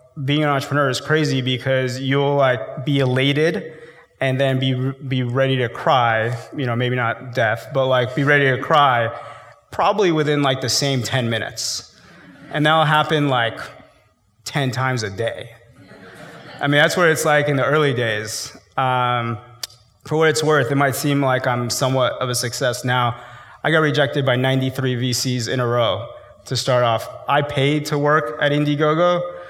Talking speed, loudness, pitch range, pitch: 175 wpm, -19 LUFS, 125-145 Hz, 135 Hz